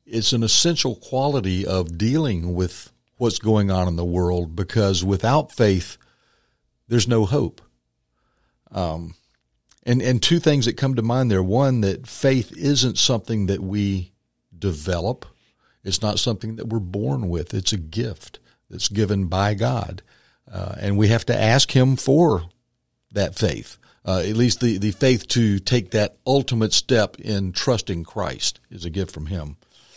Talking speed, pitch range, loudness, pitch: 160 wpm, 95-120 Hz, -21 LUFS, 105 Hz